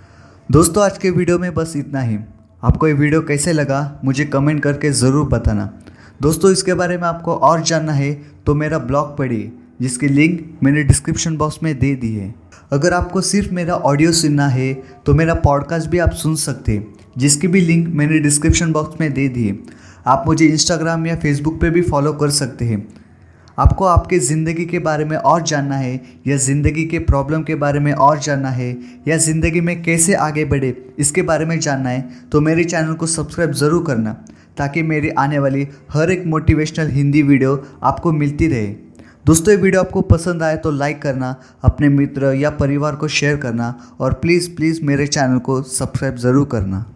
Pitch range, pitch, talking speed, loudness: 130-160 Hz, 145 Hz, 190 wpm, -16 LUFS